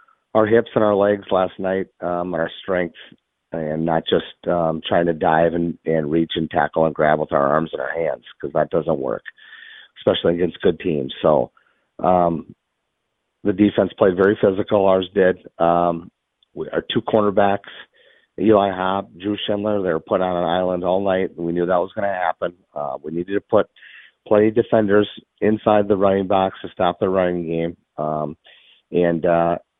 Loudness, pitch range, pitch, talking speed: -20 LUFS, 85-105 Hz, 90 Hz, 185 wpm